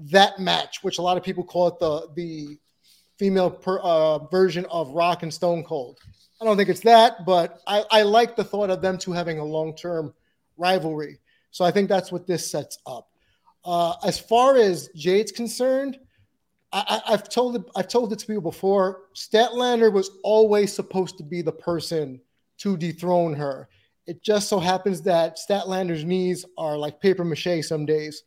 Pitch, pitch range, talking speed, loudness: 180 Hz, 165-205 Hz, 185 wpm, -22 LUFS